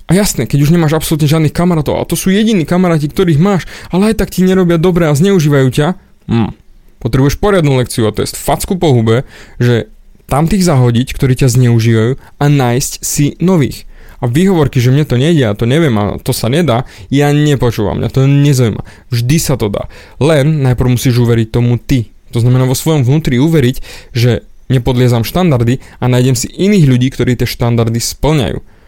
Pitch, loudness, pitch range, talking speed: 135 Hz, -11 LUFS, 120-160 Hz, 185 wpm